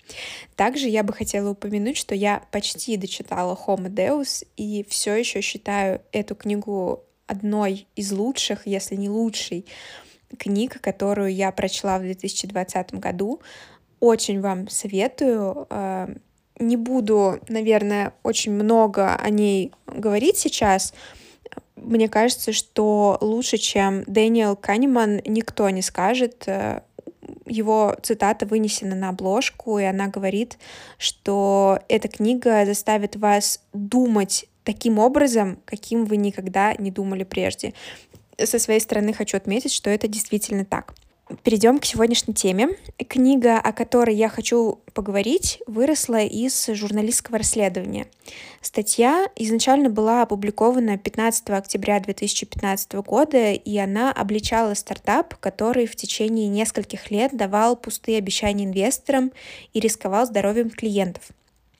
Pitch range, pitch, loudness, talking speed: 200-230 Hz, 215 Hz, -22 LUFS, 120 wpm